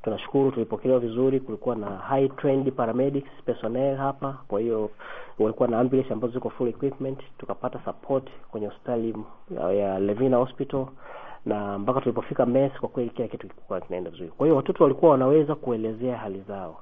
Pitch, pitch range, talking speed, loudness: 125 Hz, 110-135 Hz, 155 wpm, -26 LUFS